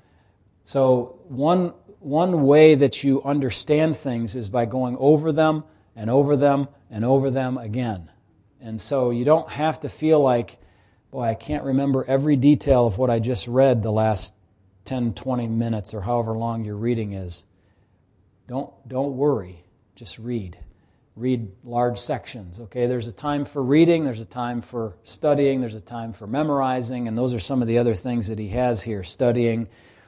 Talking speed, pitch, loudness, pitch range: 175 wpm, 120 Hz, -22 LUFS, 110-135 Hz